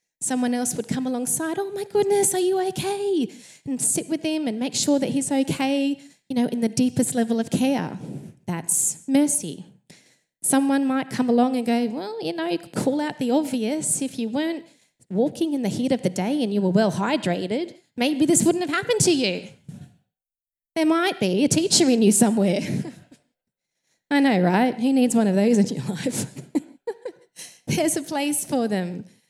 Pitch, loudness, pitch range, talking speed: 265 Hz, -22 LUFS, 230-305 Hz, 185 wpm